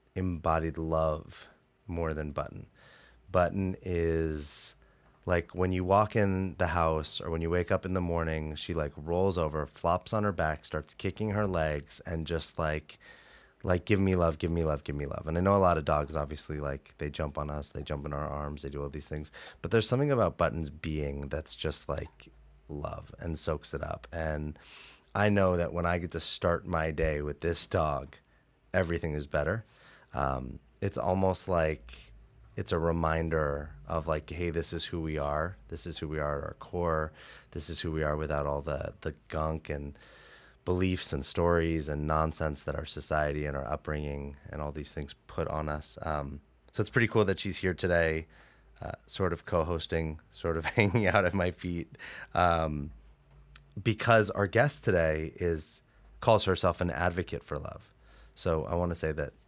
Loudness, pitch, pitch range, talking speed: -31 LUFS, 80 Hz, 75-90 Hz, 195 wpm